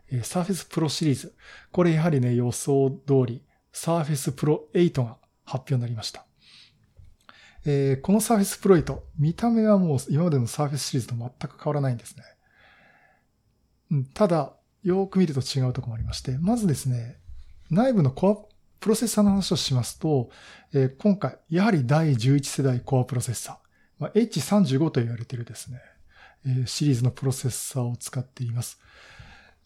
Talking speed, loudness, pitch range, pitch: 355 characters per minute, -25 LUFS, 125-175 Hz, 140 Hz